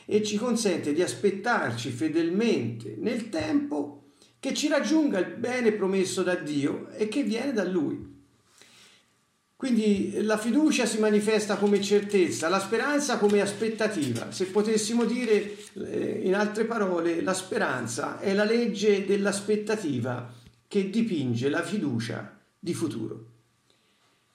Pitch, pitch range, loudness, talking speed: 205 Hz, 180-225 Hz, -27 LUFS, 125 wpm